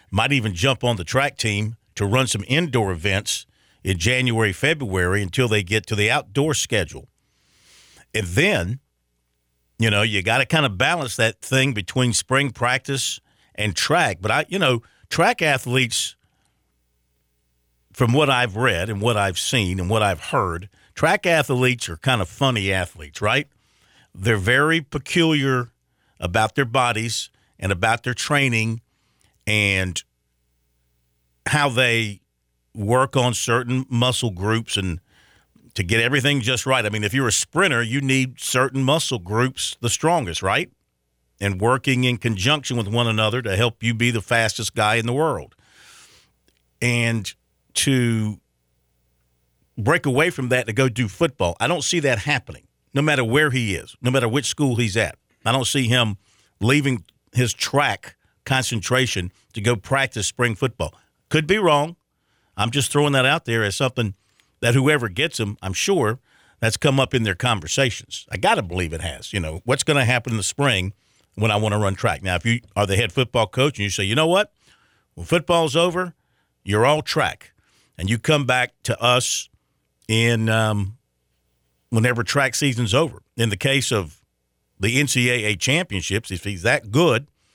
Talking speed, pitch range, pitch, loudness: 170 wpm, 100-130 Hz, 115 Hz, -20 LUFS